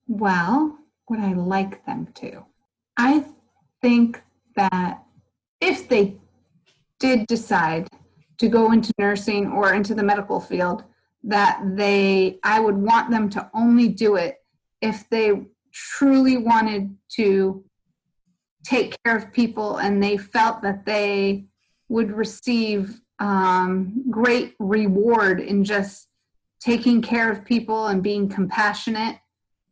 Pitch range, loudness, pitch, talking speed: 200-230 Hz, -21 LUFS, 215 Hz, 120 wpm